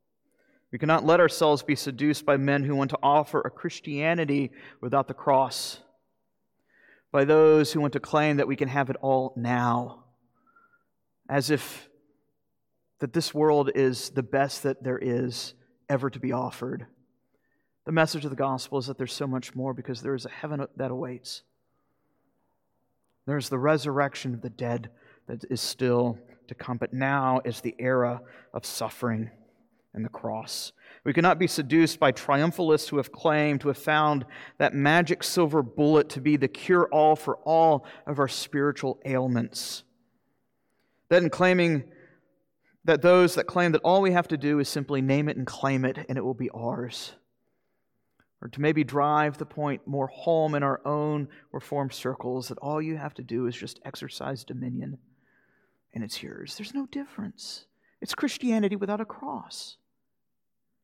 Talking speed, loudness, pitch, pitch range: 170 wpm, -26 LUFS, 140 Hz, 130-155 Hz